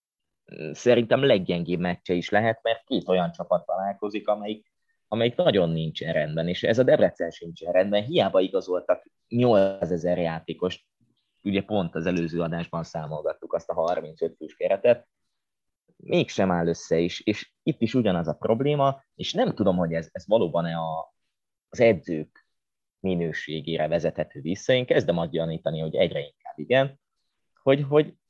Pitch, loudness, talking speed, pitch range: 90 Hz, -25 LUFS, 145 wpm, 85-115 Hz